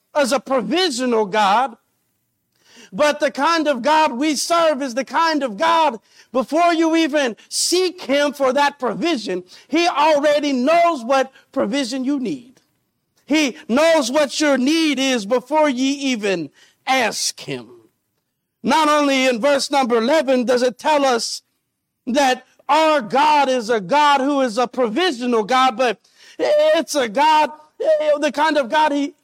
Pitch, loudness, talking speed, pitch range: 285 Hz, -18 LUFS, 150 wpm, 255-310 Hz